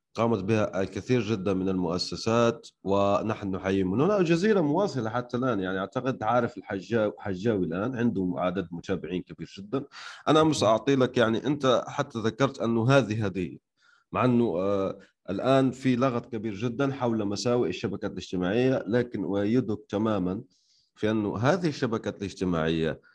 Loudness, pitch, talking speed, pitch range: -27 LUFS, 110 Hz, 145 wpm, 95-125 Hz